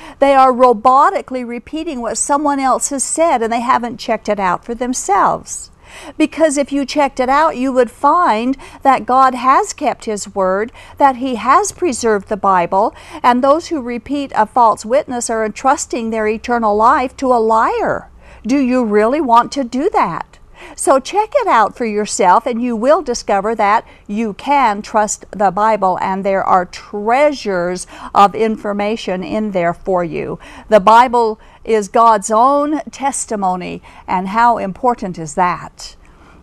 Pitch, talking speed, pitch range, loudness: 235 Hz, 160 wpm, 210-270 Hz, -14 LUFS